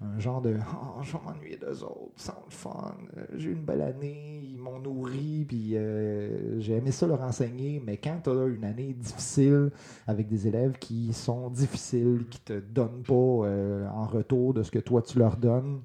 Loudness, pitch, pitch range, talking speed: -29 LUFS, 125 Hz, 110-135 Hz, 200 wpm